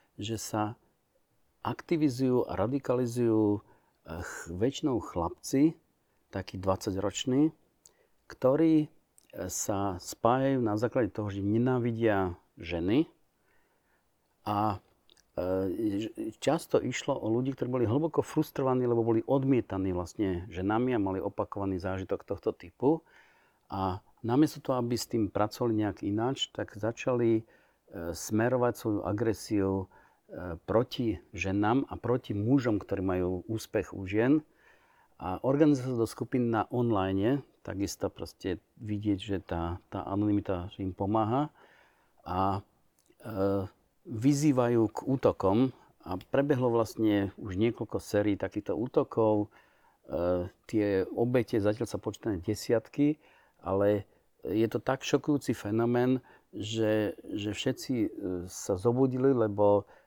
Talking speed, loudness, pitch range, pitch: 110 wpm, -30 LUFS, 100-130 Hz, 110 Hz